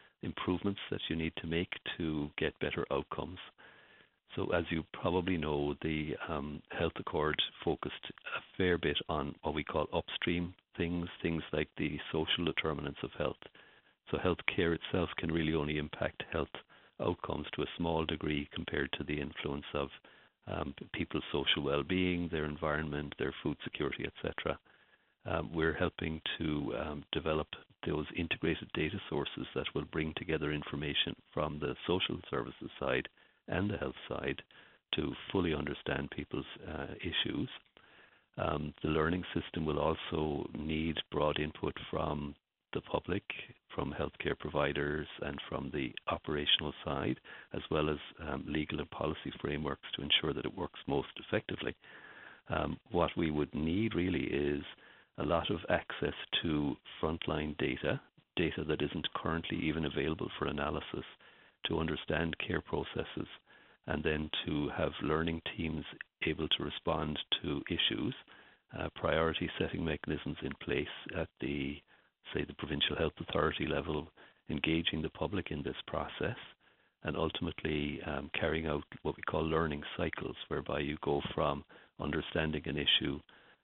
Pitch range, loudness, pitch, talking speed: 75-80 Hz, -36 LUFS, 80 Hz, 145 wpm